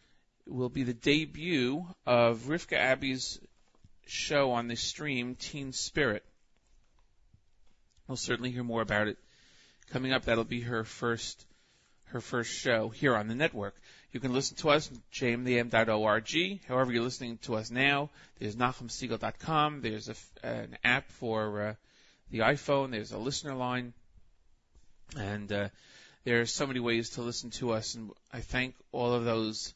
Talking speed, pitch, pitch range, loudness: 155 wpm, 120 Hz, 110-130 Hz, -32 LUFS